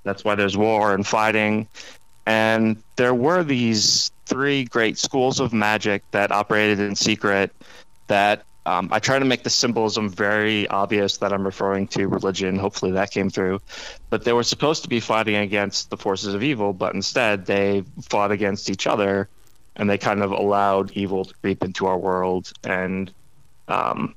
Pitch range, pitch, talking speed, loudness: 100-110 Hz, 105 Hz, 175 wpm, -21 LUFS